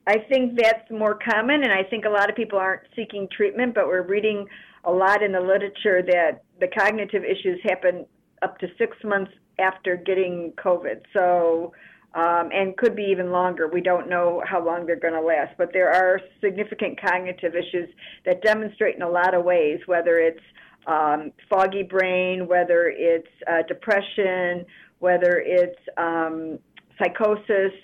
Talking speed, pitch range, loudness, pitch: 165 wpm, 175-205 Hz, -22 LUFS, 185 Hz